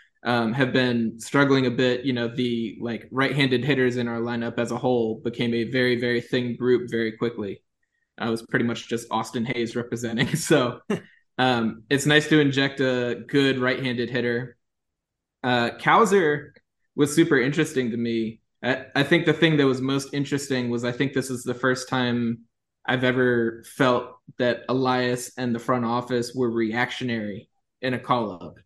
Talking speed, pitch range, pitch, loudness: 175 wpm, 120-130 Hz, 125 Hz, -24 LUFS